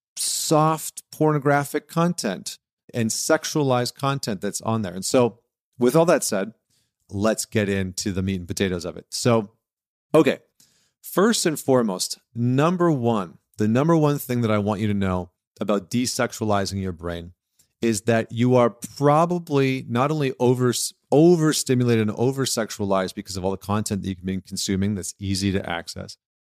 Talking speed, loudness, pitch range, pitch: 155 wpm, -22 LUFS, 100-135 Hz, 115 Hz